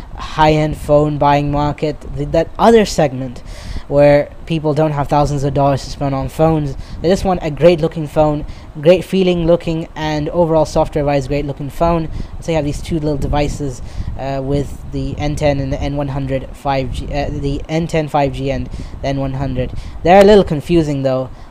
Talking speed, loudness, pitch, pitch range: 180 wpm, -16 LUFS, 145 Hz, 135-160 Hz